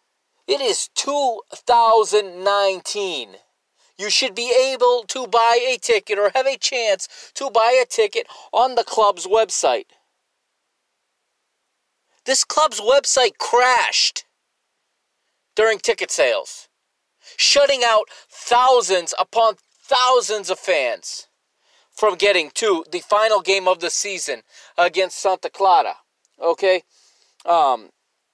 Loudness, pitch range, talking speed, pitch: -18 LUFS, 205-285 Hz, 110 wpm, 235 Hz